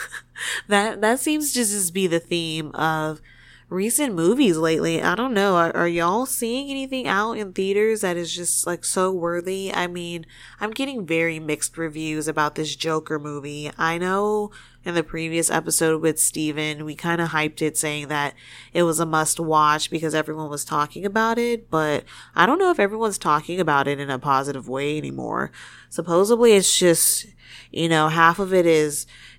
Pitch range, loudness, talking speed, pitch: 155-195 Hz, -21 LUFS, 180 wpm, 165 Hz